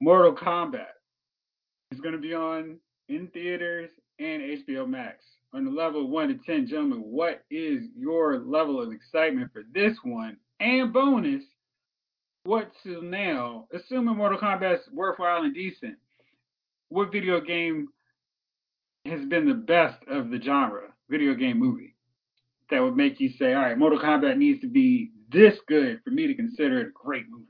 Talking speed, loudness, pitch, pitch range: 165 wpm, -26 LUFS, 230 Hz, 170-265 Hz